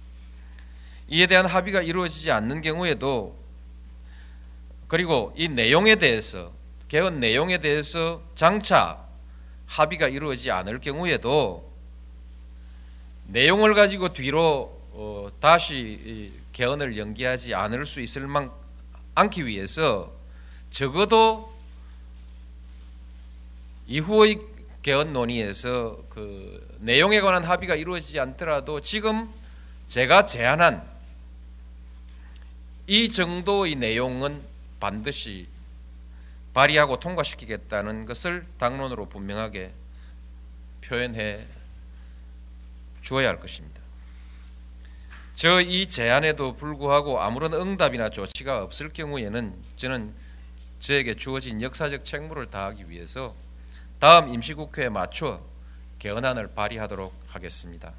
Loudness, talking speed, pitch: -23 LUFS, 235 characters per minute, 95 Hz